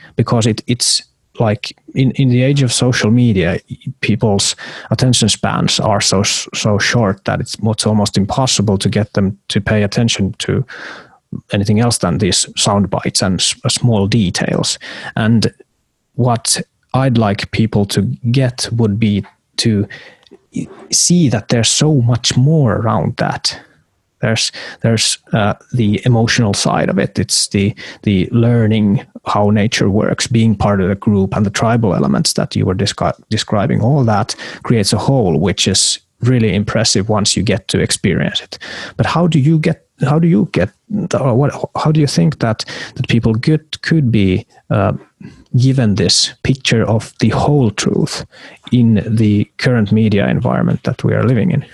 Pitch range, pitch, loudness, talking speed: 105-130 Hz, 115 Hz, -14 LUFS, 160 wpm